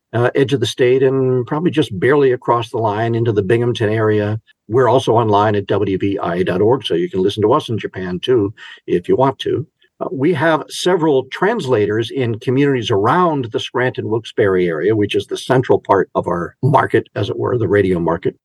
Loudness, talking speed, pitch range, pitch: -16 LUFS, 190 wpm, 110-135 Hz, 120 Hz